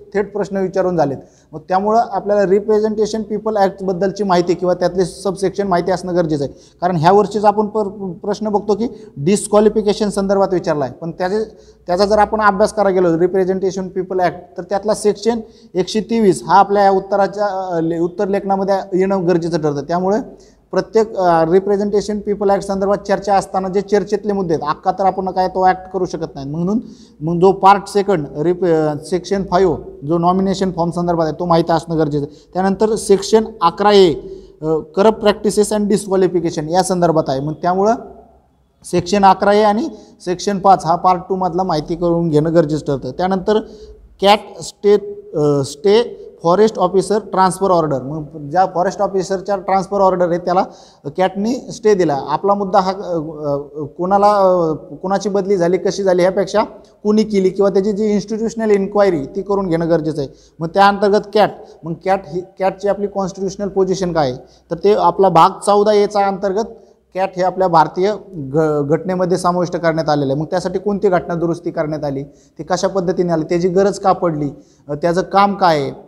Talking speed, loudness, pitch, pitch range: 165 wpm, -16 LUFS, 190 Hz, 175-205 Hz